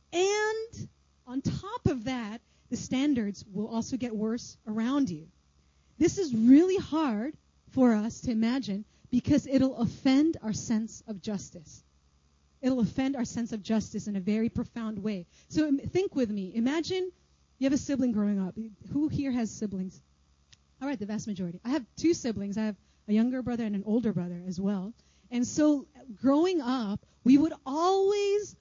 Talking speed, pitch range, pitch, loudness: 170 wpm, 210-275 Hz, 235 Hz, -29 LUFS